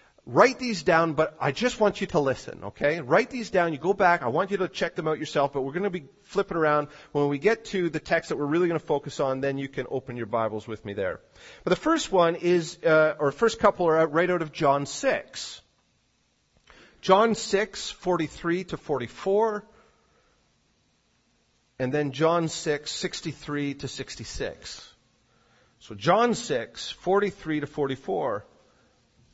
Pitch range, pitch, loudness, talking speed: 140-190 Hz, 160 Hz, -26 LUFS, 180 wpm